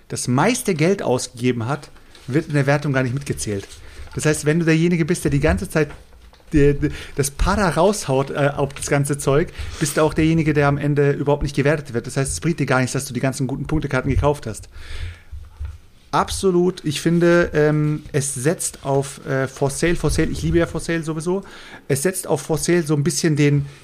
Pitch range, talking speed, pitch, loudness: 130-160 Hz, 215 wpm, 145 Hz, -20 LUFS